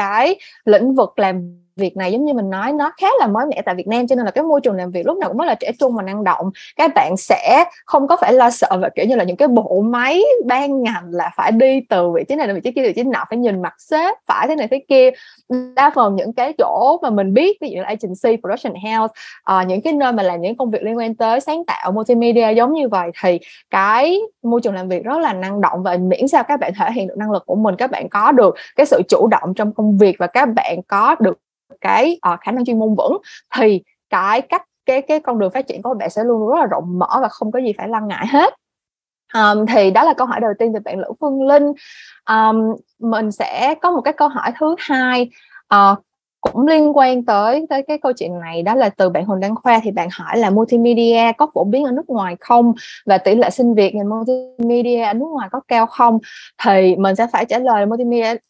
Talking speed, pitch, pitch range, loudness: 255 wpm, 235 Hz, 205-275 Hz, -16 LUFS